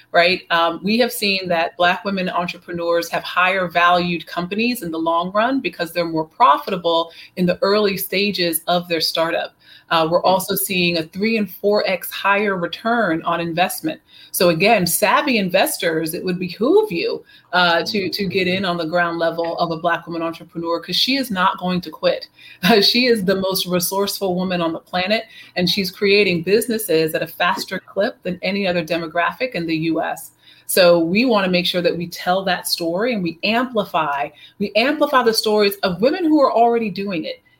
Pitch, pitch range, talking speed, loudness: 180 Hz, 170-210 Hz, 190 wpm, -18 LUFS